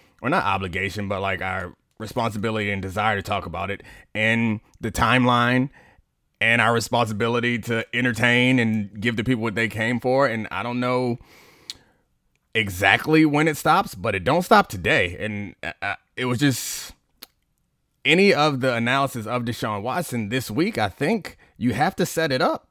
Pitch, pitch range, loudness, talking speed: 115 Hz, 105-125 Hz, -22 LUFS, 170 wpm